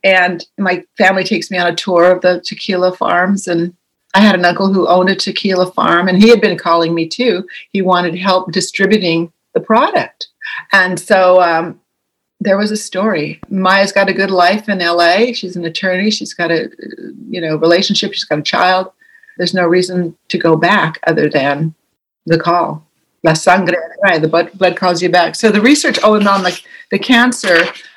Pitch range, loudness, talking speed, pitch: 170-200 Hz, -12 LUFS, 185 wpm, 185 Hz